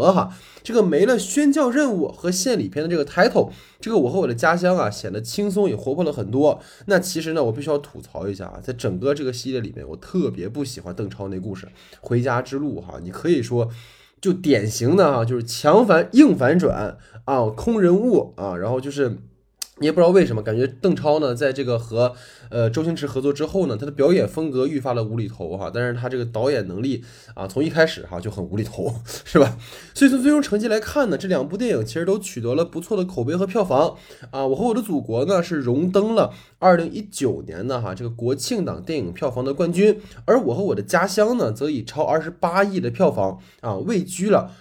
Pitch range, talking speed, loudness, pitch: 115-185 Hz, 335 characters per minute, -21 LUFS, 140 Hz